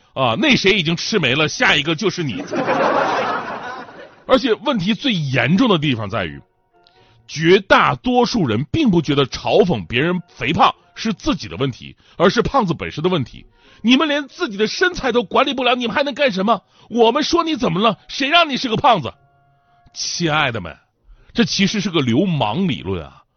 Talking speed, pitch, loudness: 265 characters per minute, 190 Hz, -17 LUFS